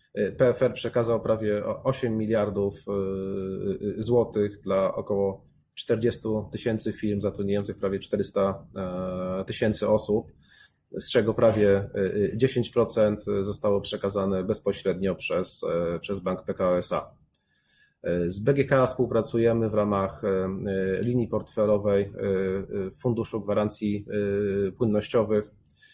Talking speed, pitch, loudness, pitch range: 90 wpm, 105 Hz, -27 LUFS, 100-110 Hz